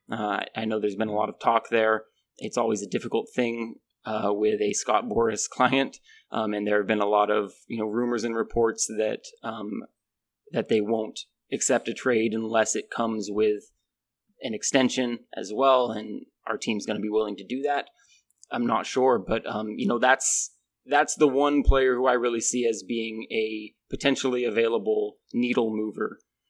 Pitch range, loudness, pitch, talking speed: 110-125 Hz, -26 LUFS, 115 Hz, 190 wpm